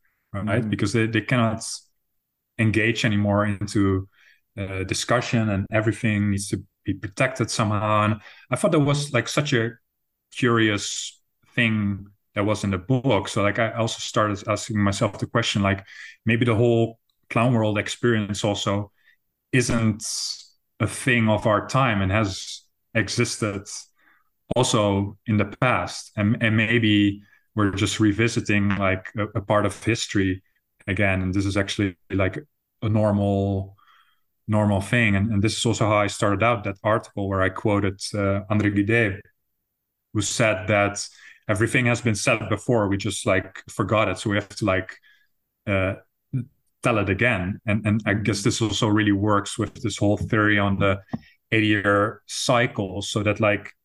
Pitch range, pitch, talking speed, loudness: 100-115 Hz, 105 Hz, 160 wpm, -23 LUFS